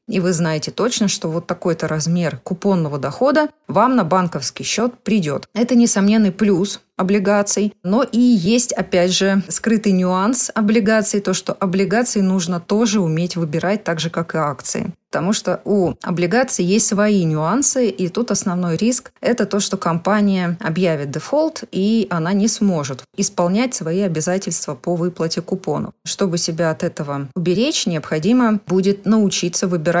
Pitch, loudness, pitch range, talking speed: 190 Hz, -18 LUFS, 175-215 Hz, 150 wpm